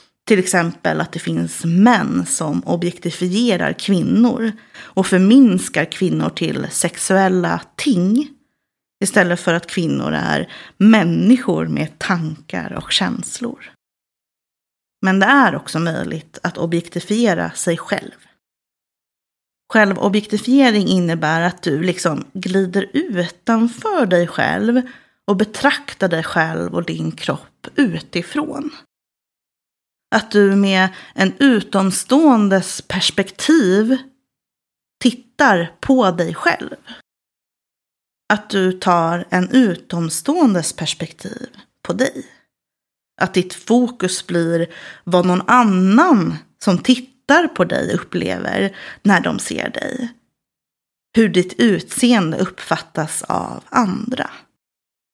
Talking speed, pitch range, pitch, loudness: 100 wpm, 175-240 Hz, 195 Hz, -17 LUFS